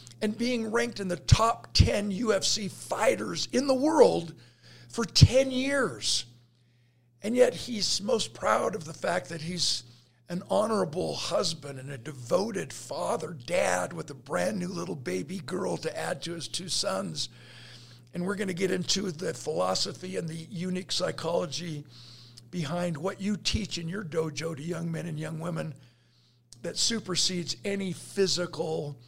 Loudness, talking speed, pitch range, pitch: -29 LUFS, 155 wpm, 135-190 Hz, 170 Hz